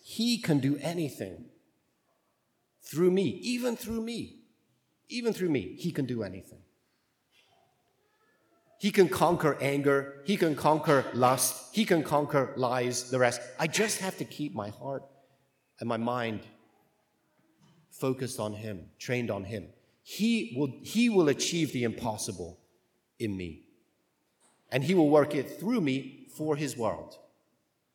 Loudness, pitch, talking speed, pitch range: -29 LUFS, 140 Hz, 140 wpm, 120-165 Hz